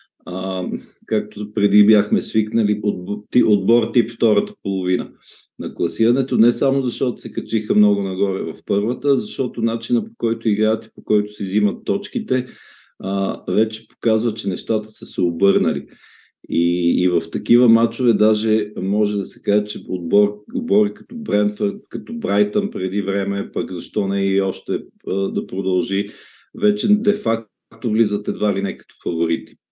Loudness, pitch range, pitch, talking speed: -19 LUFS, 100-120 Hz, 105 Hz, 145 wpm